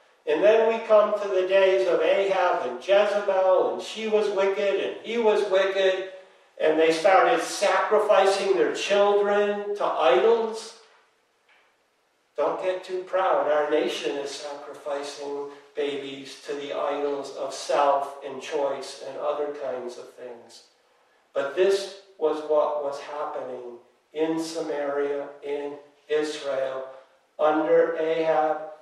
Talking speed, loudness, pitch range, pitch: 125 wpm, -24 LUFS, 145-195 Hz, 160 Hz